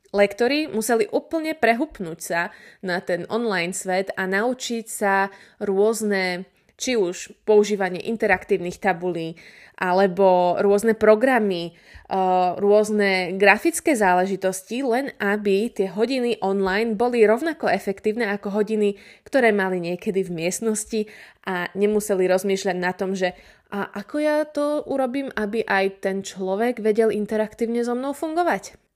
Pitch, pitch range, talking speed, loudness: 205 Hz, 190-230 Hz, 120 wpm, -22 LUFS